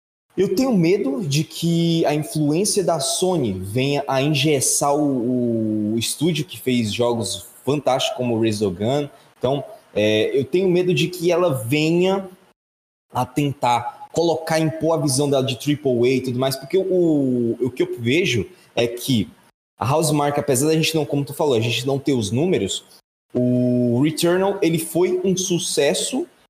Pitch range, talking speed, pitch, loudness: 125-165 Hz, 170 wpm, 145 Hz, -20 LUFS